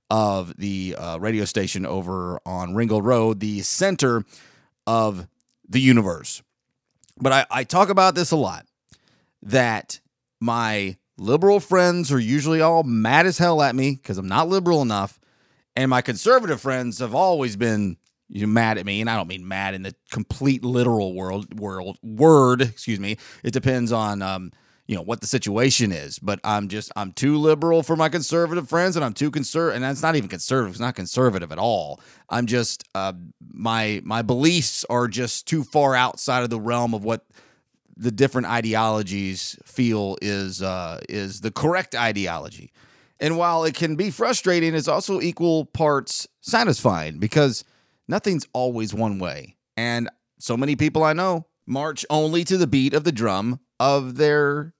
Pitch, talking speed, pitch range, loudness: 125 Hz, 170 wpm, 105-155 Hz, -22 LUFS